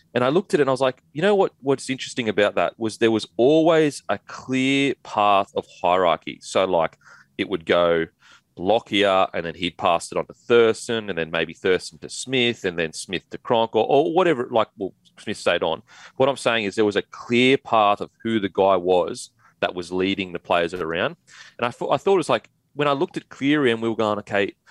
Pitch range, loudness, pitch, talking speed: 95-135 Hz, -22 LUFS, 115 Hz, 235 wpm